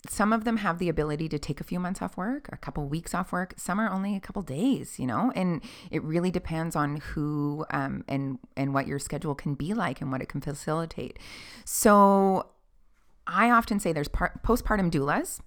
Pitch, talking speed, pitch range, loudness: 165 Hz, 210 wpm, 150-200 Hz, -28 LUFS